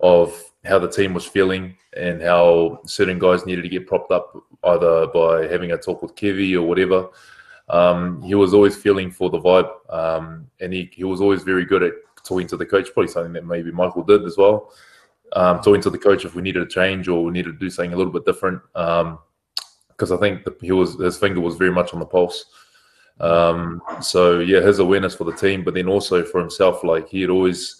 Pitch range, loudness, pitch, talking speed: 85-95 Hz, -19 LUFS, 90 Hz, 225 wpm